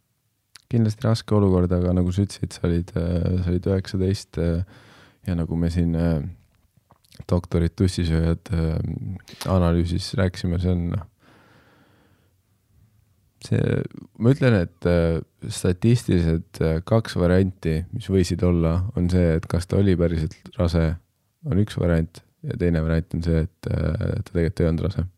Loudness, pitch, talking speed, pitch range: -23 LUFS, 90 Hz, 130 wpm, 85-105 Hz